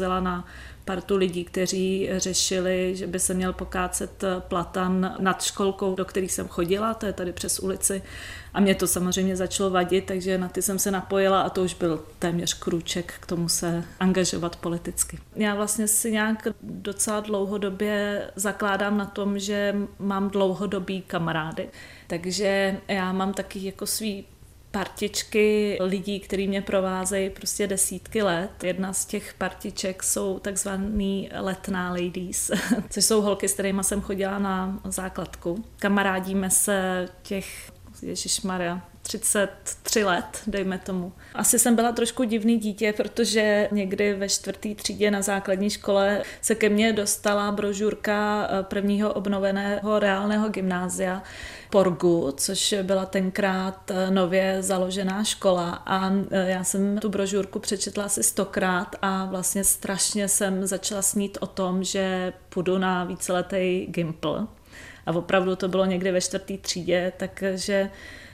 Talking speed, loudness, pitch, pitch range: 140 wpm, -25 LUFS, 195 Hz, 185-205 Hz